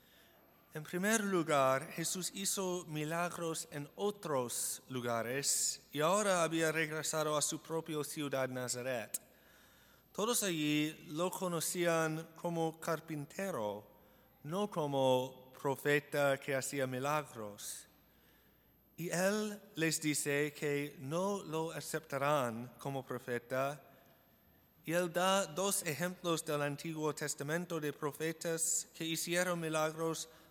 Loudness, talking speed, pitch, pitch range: -36 LUFS, 105 wpm, 155 Hz, 140-170 Hz